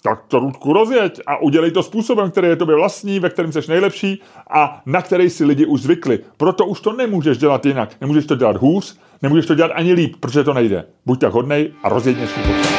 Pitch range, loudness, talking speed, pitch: 145-195 Hz, -16 LUFS, 220 wpm, 165 Hz